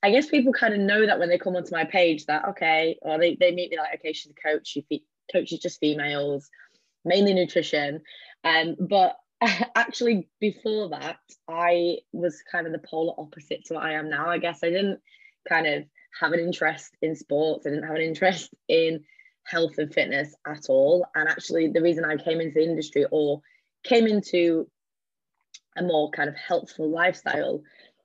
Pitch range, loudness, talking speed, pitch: 155-190 Hz, -25 LUFS, 190 wpm, 170 Hz